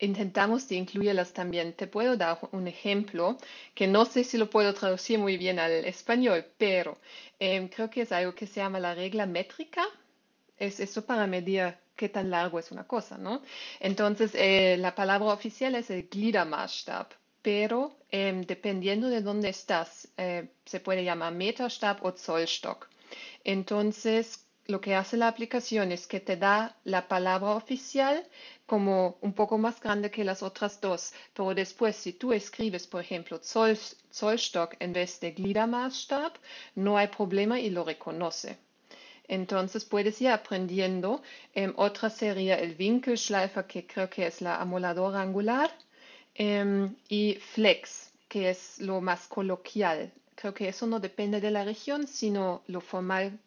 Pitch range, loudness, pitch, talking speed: 185-225 Hz, -30 LUFS, 200 Hz, 155 wpm